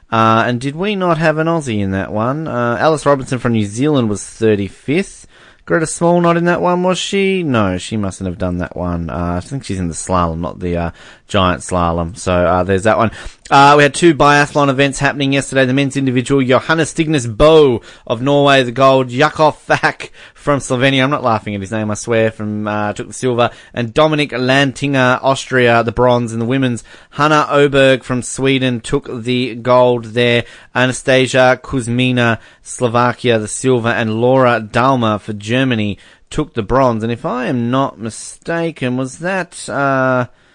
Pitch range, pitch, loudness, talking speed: 110-140 Hz, 125 Hz, -14 LUFS, 185 wpm